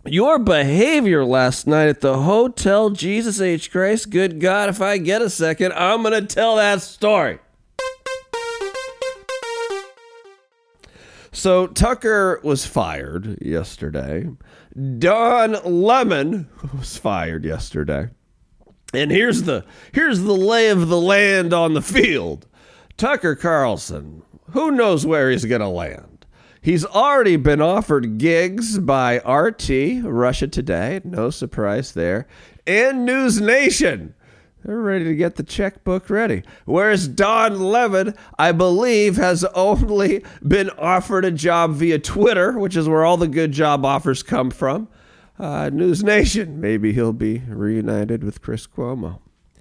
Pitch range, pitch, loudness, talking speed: 140-215 Hz, 185 Hz, -18 LUFS, 130 wpm